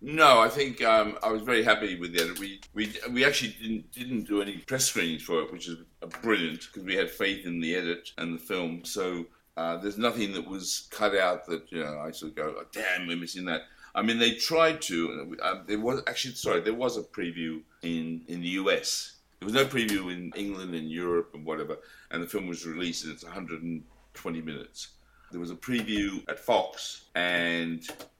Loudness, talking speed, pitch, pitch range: -29 LUFS, 220 wpm, 90 Hz, 85-105 Hz